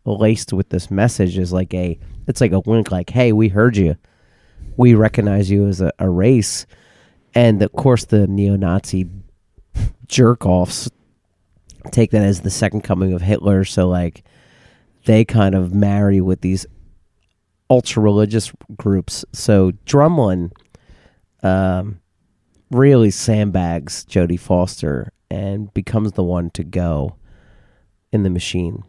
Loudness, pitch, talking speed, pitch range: -17 LUFS, 100 Hz, 130 wpm, 90-110 Hz